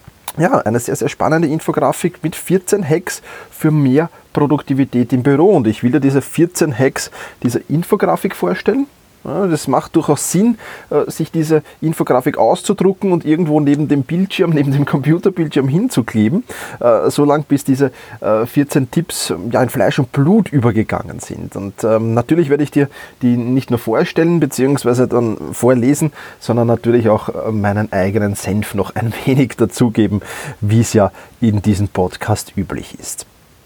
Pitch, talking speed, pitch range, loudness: 140 Hz, 145 wpm, 115-160 Hz, -15 LUFS